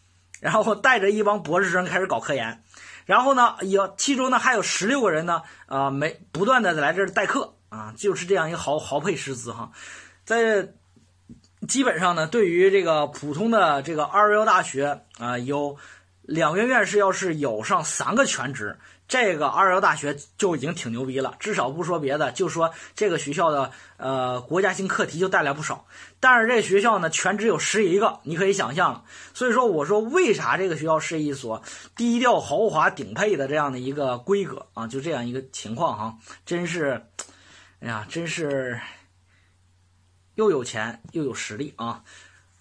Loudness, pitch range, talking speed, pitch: -23 LUFS, 120-200 Hz, 270 characters per minute, 155 Hz